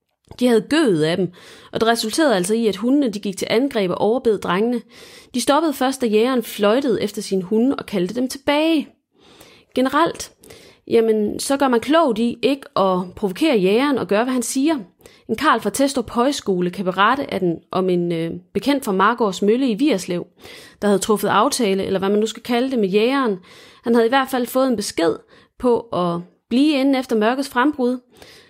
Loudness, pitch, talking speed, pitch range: -19 LUFS, 230 Hz, 195 wpm, 200-260 Hz